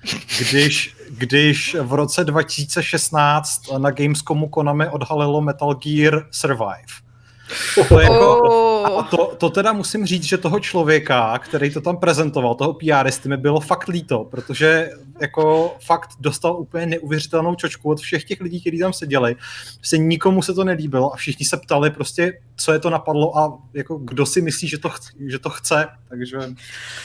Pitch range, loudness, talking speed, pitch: 140-170 Hz, -18 LUFS, 165 wpm, 155 Hz